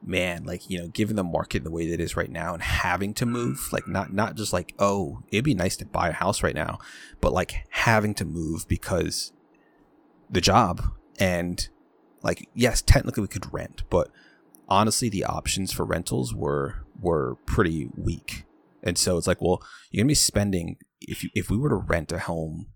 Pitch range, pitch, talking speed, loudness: 85-105 Hz, 90 Hz, 200 wpm, -26 LUFS